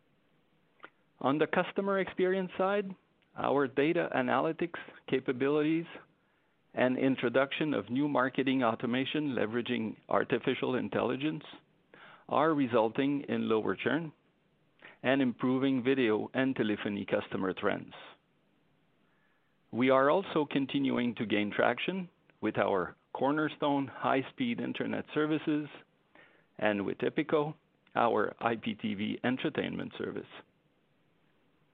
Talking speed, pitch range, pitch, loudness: 95 wpm, 130-165 Hz, 145 Hz, -31 LUFS